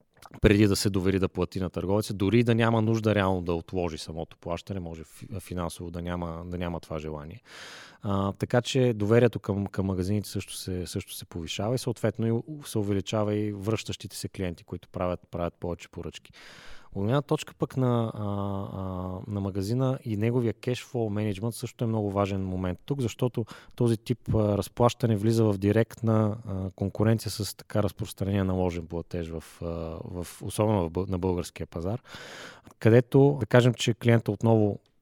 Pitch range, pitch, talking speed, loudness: 90-115 Hz, 105 Hz, 160 wpm, -28 LUFS